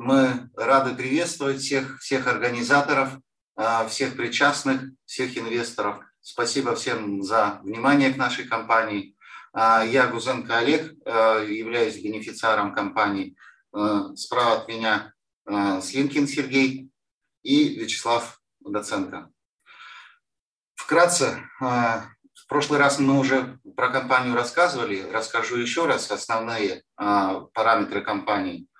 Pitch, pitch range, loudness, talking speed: 125 Hz, 115-135 Hz, -23 LUFS, 95 wpm